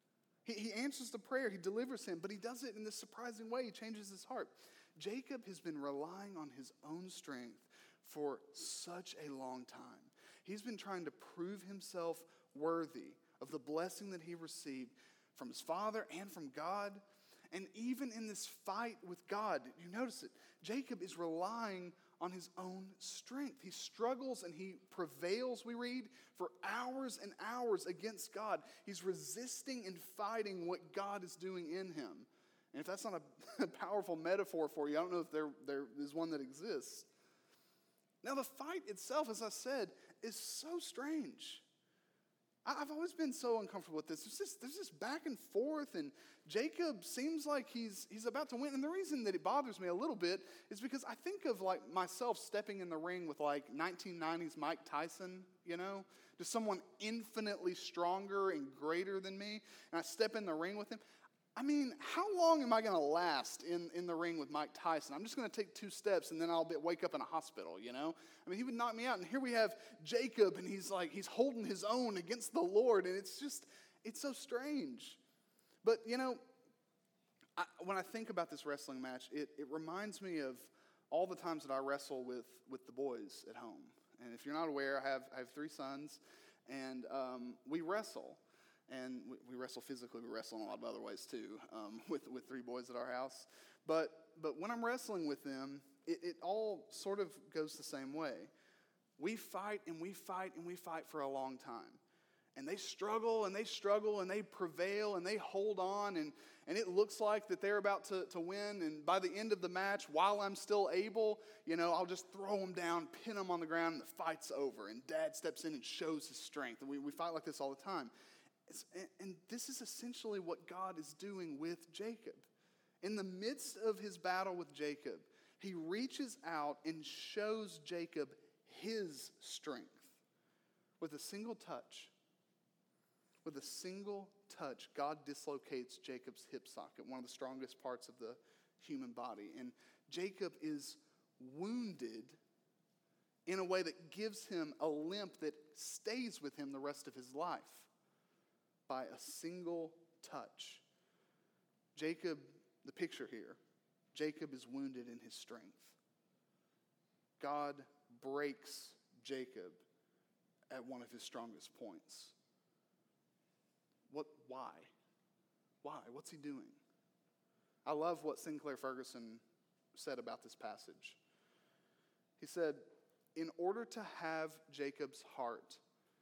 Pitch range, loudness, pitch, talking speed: 160-235 Hz, -44 LUFS, 190 Hz, 180 wpm